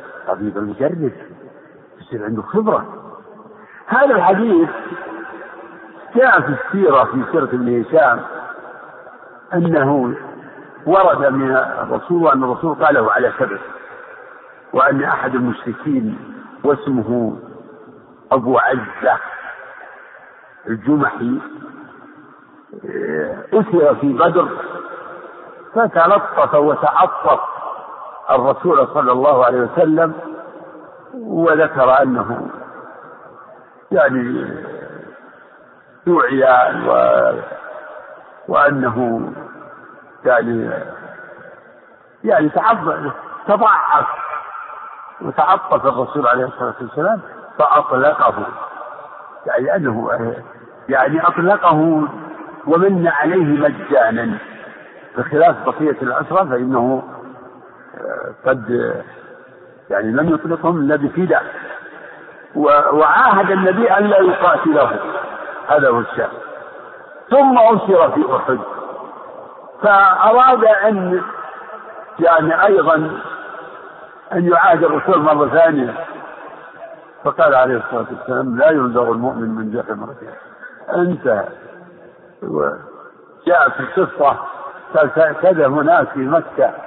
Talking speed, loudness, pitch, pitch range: 75 wpm, -15 LUFS, 165 Hz, 130-210 Hz